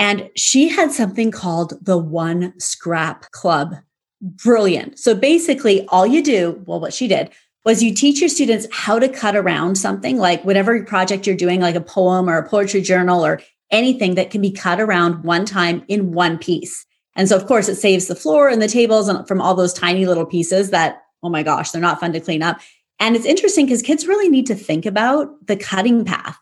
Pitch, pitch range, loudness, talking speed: 195 Hz, 175-225 Hz, -16 LUFS, 210 wpm